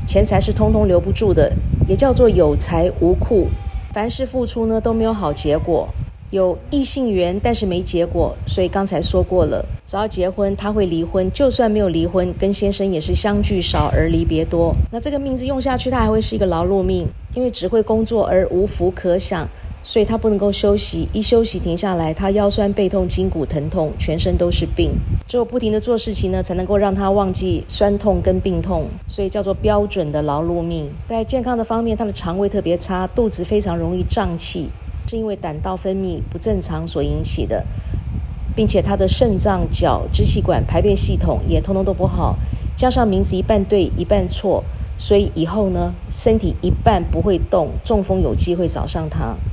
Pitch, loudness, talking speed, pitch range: 195 Hz, -18 LUFS, 290 characters per minute, 170-220 Hz